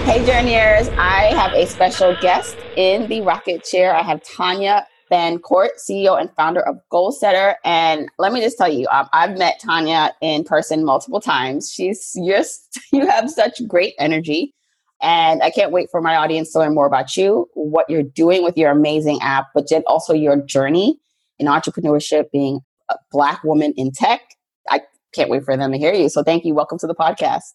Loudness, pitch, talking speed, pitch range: -17 LUFS, 165 Hz, 190 wpm, 150-195 Hz